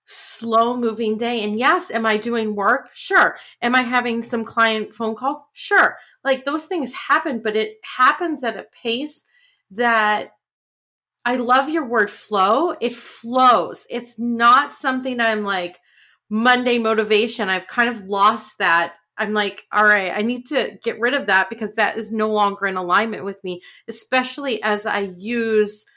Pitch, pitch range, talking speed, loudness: 230 Hz, 210-250 Hz, 165 wpm, -19 LUFS